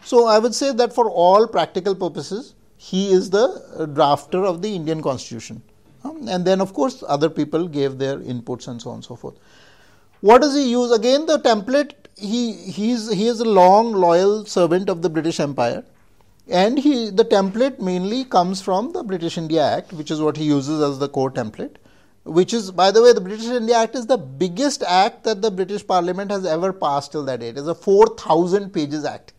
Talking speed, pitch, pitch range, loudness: 210 wpm, 185 Hz, 155-225 Hz, -19 LUFS